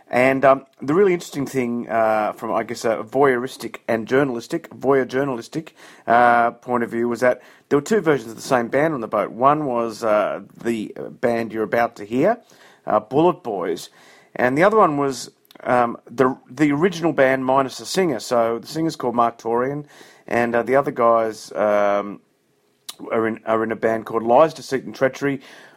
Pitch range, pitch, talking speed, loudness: 115-135 Hz, 120 Hz, 190 wpm, -20 LUFS